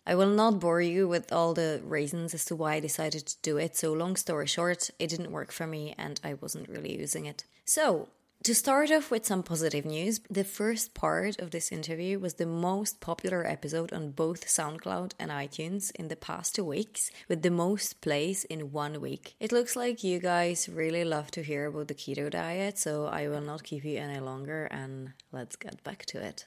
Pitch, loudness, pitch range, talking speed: 165 Hz, -31 LUFS, 150-185 Hz, 215 wpm